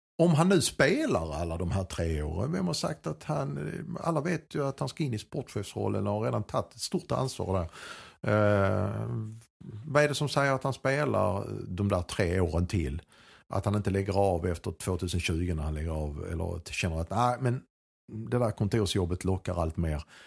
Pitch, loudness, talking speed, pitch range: 105 Hz, -30 LUFS, 210 wpm, 90-125 Hz